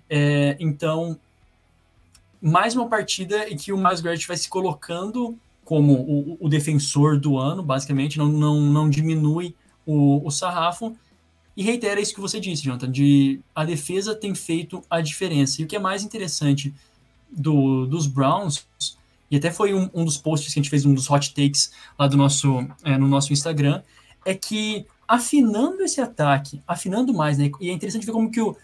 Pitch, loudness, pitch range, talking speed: 155 Hz, -22 LUFS, 140-190 Hz, 180 wpm